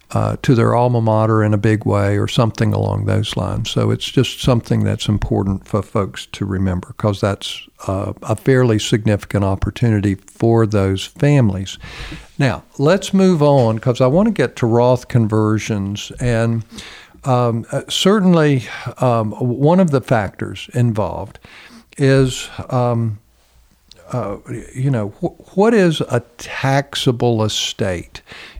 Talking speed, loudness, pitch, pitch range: 140 wpm, -17 LUFS, 115 Hz, 105-130 Hz